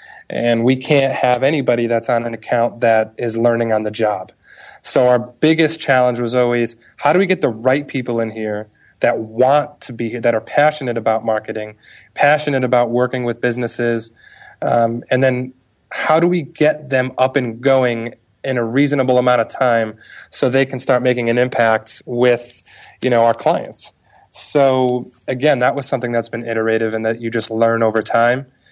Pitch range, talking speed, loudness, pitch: 115-130 Hz, 185 wpm, -17 LUFS, 120 Hz